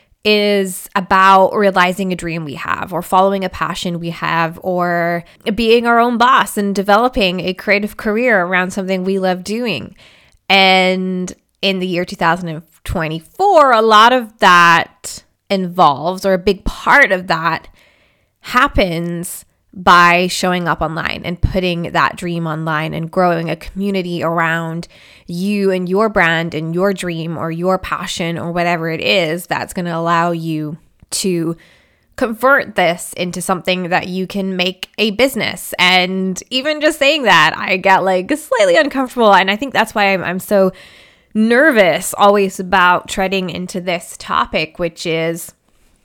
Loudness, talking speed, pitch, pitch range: -14 LUFS, 150 wpm, 185 Hz, 170-200 Hz